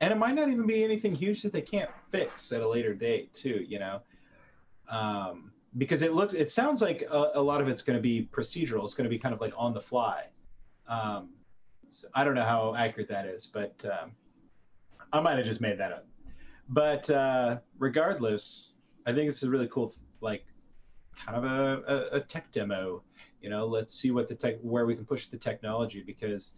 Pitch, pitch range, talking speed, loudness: 125 Hz, 110-150 Hz, 210 wpm, -31 LUFS